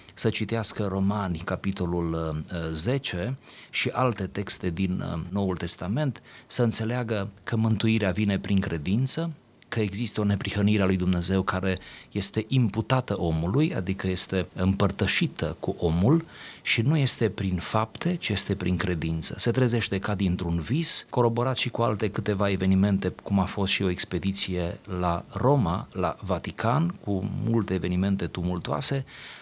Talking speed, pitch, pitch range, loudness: 140 wpm, 100 Hz, 90-115 Hz, -25 LUFS